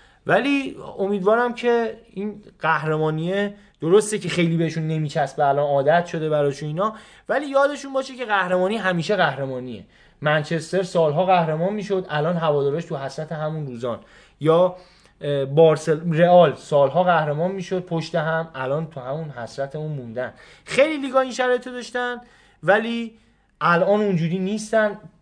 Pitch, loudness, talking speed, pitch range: 175 Hz, -21 LUFS, 130 wpm, 155-205 Hz